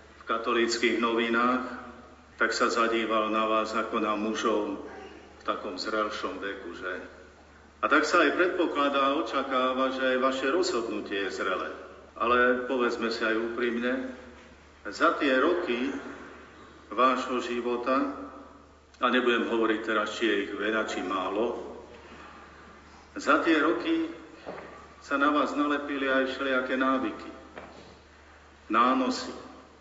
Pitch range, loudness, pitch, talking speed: 105-130 Hz, -27 LUFS, 120 Hz, 115 wpm